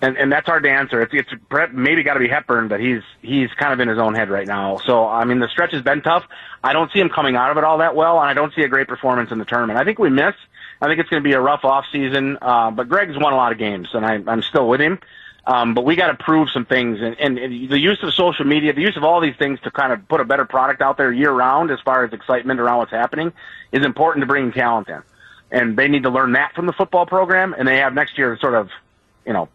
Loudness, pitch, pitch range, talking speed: -17 LUFS, 135 Hz, 120-155 Hz, 295 wpm